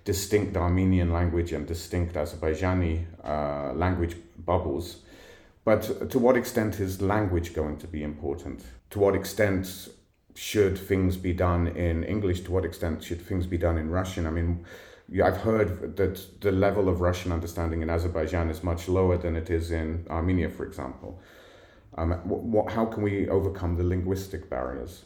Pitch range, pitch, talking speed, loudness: 85-95 Hz, 90 Hz, 165 wpm, -28 LUFS